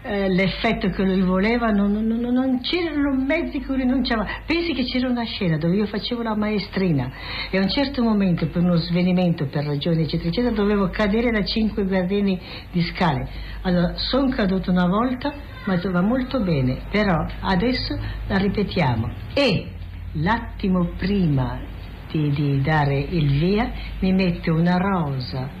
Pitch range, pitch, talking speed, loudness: 165-225 Hz, 190 Hz, 155 wpm, -22 LUFS